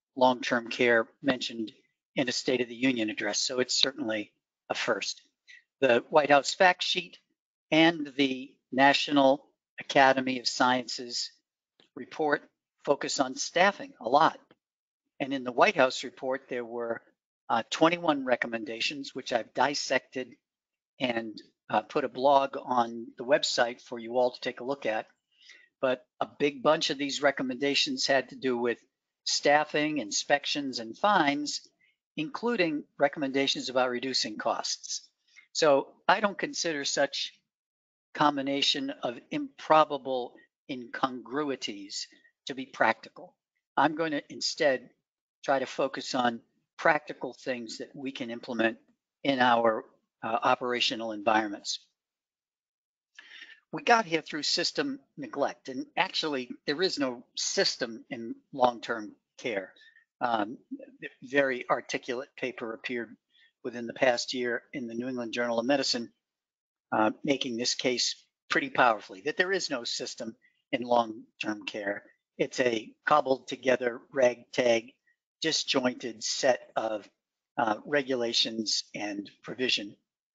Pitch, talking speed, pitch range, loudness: 135 Hz, 130 wpm, 125-175 Hz, -29 LUFS